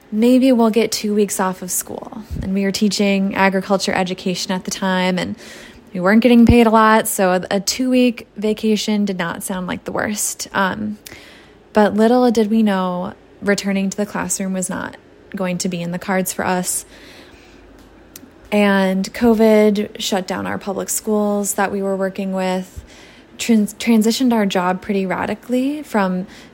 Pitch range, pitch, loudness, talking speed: 190-220 Hz, 200 Hz, -17 LUFS, 165 wpm